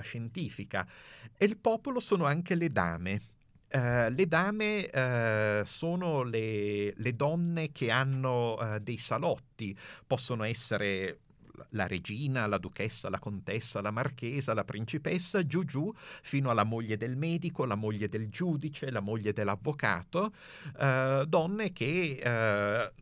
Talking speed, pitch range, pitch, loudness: 135 wpm, 105-160 Hz, 125 Hz, -32 LUFS